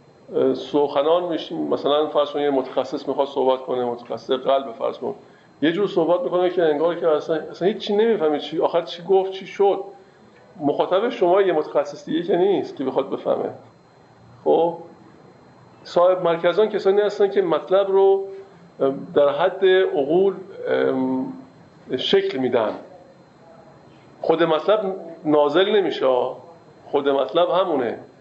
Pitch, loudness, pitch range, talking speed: 175 Hz, -21 LUFS, 145-195 Hz, 130 wpm